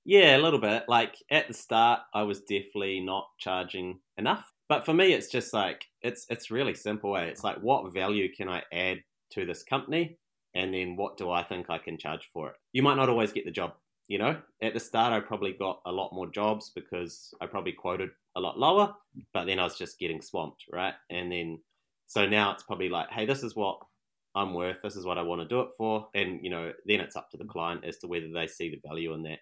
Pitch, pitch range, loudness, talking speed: 100 Hz, 90-115 Hz, -30 LUFS, 245 wpm